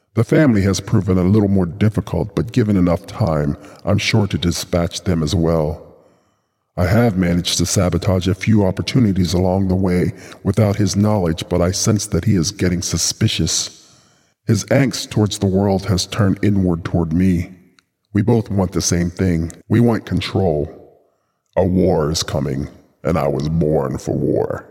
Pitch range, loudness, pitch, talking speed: 85-105 Hz, -17 LUFS, 95 Hz, 170 wpm